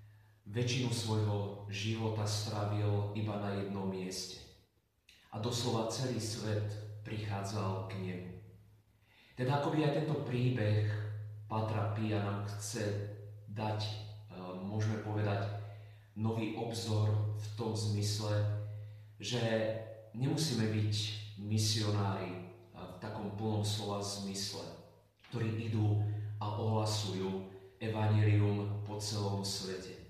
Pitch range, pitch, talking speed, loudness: 100-110 Hz, 105 Hz, 95 wpm, -36 LUFS